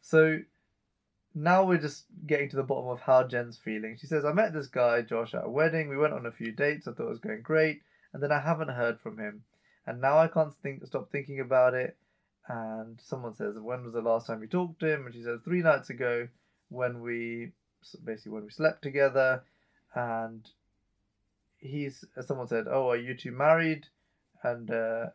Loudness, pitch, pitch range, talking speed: -30 LUFS, 130 Hz, 115-155 Hz, 205 wpm